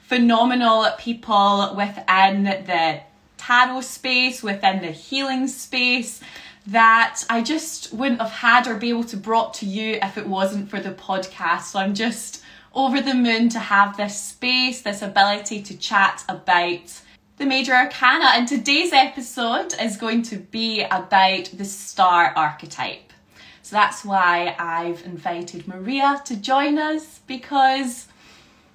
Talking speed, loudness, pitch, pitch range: 140 wpm, -20 LUFS, 225 Hz, 195-255 Hz